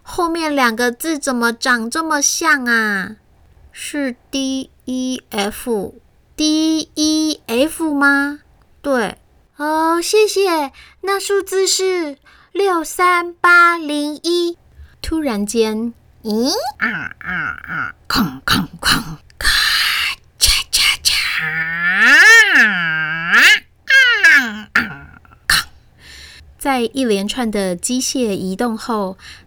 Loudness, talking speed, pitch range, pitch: -15 LUFS, 125 characters per minute, 245-350 Hz, 295 Hz